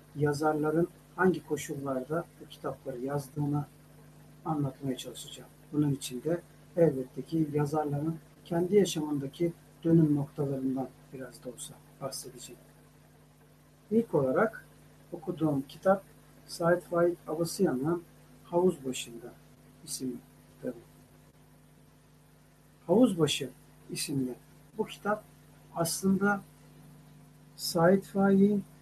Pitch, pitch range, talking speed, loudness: 150 Hz, 140-170 Hz, 85 wpm, -31 LUFS